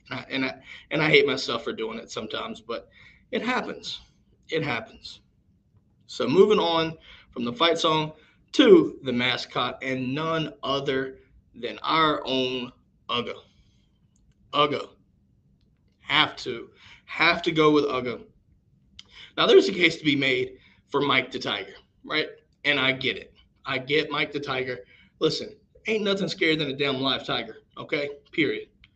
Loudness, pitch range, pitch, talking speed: -24 LUFS, 130-165 Hz, 145 Hz, 155 wpm